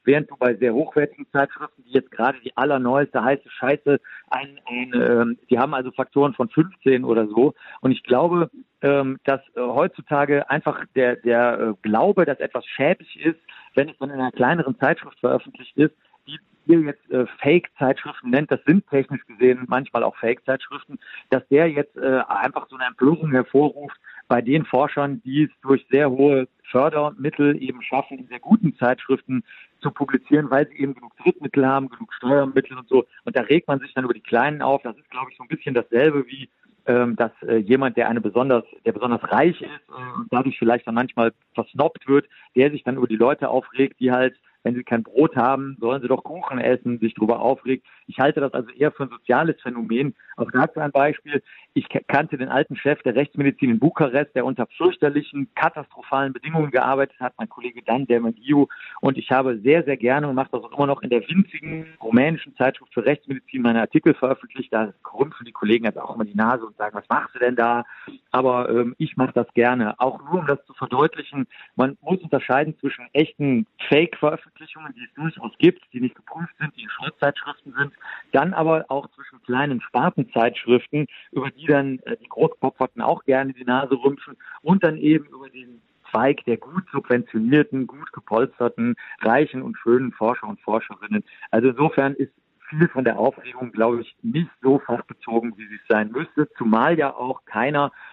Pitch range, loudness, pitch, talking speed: 125-145 Hz, -21 LUFS, 135 Hz, 190 wpm